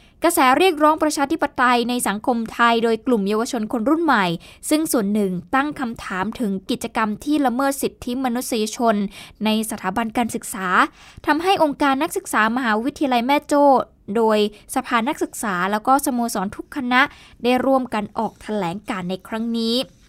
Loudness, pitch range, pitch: -20 LUFS, 215-275 Hz, 245 Hz